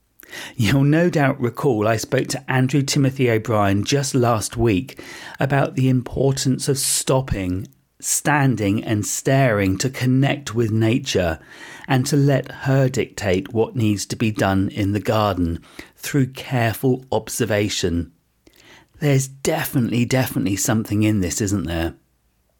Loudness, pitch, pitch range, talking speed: -20 LUFS, 125 Hz, 105-135 Hz, 130 wpm